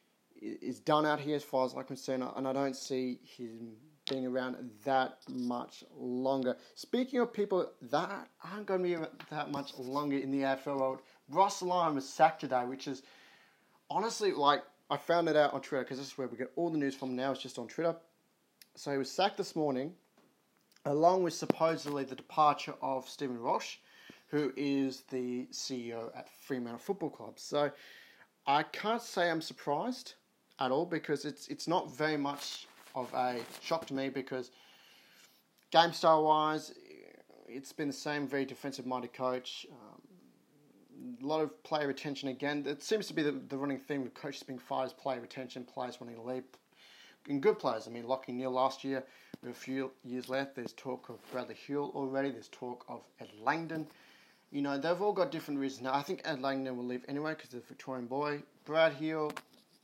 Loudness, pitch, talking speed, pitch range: -35 LUFS, 140 Hz, 190 wpm, 130-160 Hz